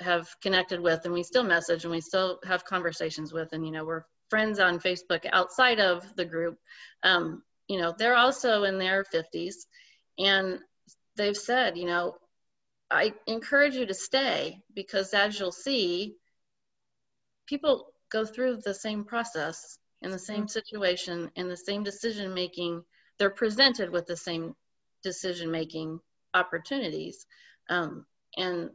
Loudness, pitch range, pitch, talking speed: -28 LUFS, 175-220 Hz, 185 Hz, 150 wpm